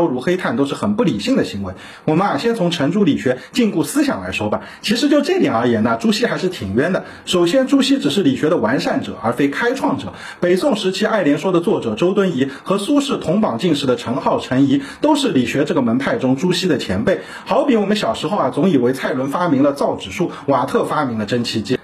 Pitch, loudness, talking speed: 185 Hz, -17 LUFS, 355 characters per minute